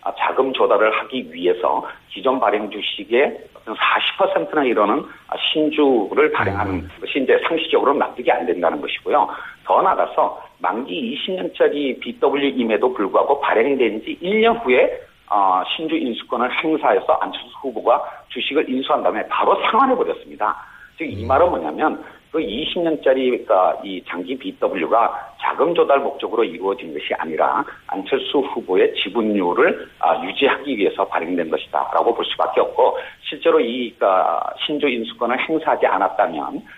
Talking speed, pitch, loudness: 330 characters per minute, 315 Hz, -19 LUFS